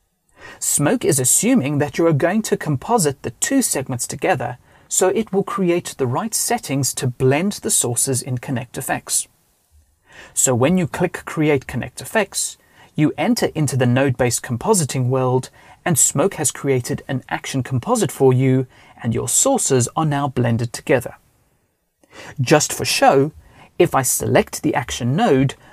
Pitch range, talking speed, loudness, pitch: 130-175 Hz, 150 wpm, -18 LUFS, 135 Hz